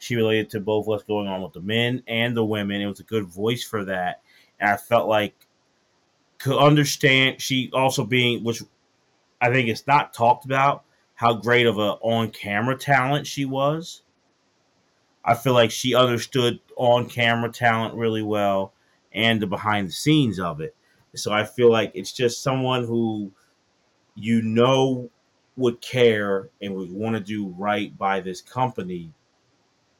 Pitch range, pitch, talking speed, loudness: 105-130 Hz, 115 Hz, 160 wpm, -22 LUFS